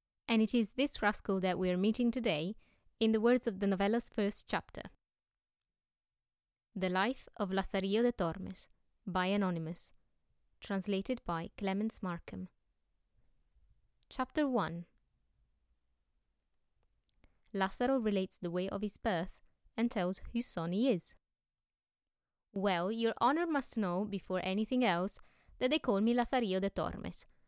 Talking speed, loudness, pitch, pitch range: 130 wpm, -35 LUFS, 195 Hz, 180-235 Hz